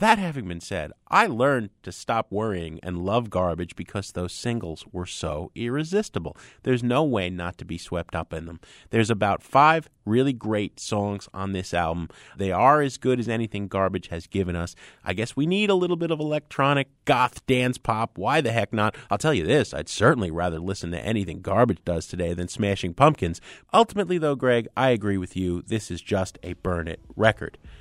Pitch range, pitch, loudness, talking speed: 90-125 Hz, 105 Hz, -25 LUFS, 200 wpm